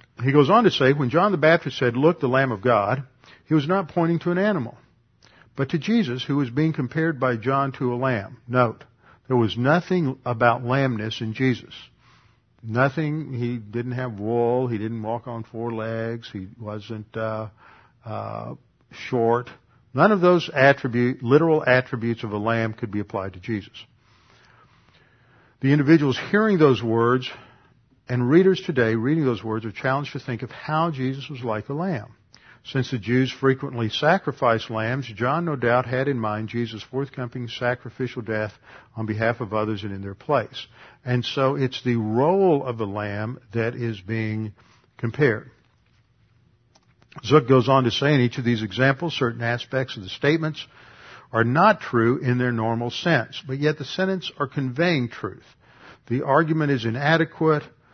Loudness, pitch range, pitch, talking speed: -23 LUFS, 115-140 Hz, 125 Hz, 170 wpm